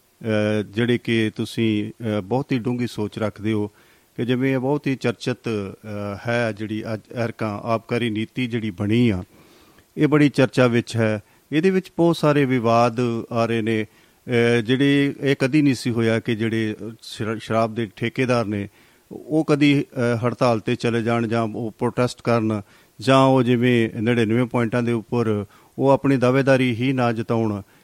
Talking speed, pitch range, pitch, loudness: 150 wpm, 110-125 Hz, 120 Hz, -21 LUFS